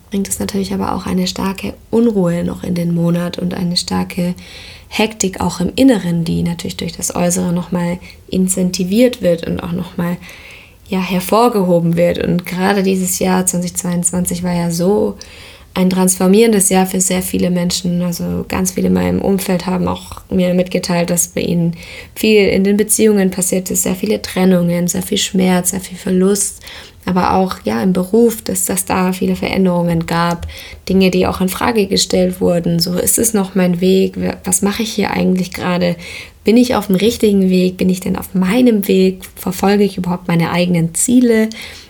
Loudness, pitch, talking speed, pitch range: -15 LUFS, 185 Hz, 180 wpm, 175-195 Hz